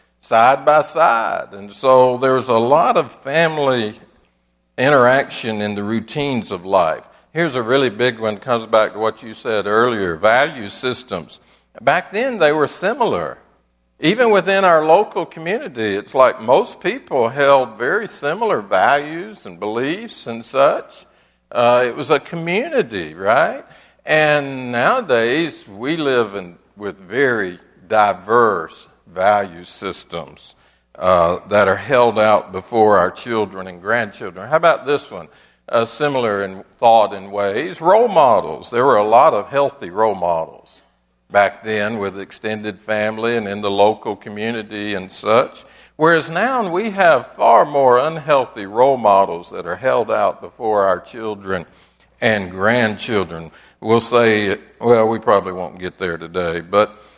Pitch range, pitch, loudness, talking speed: 100-135 Hz, 115 Hz, -17 LUFS, 145 wpm